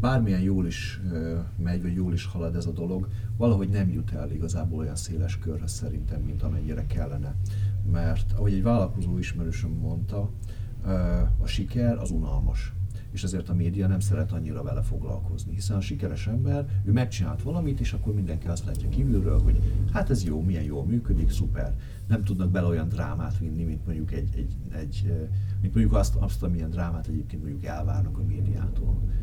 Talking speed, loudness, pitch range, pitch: 175 wpm, -28 LUFS, 90-105 Hz, 95 Hz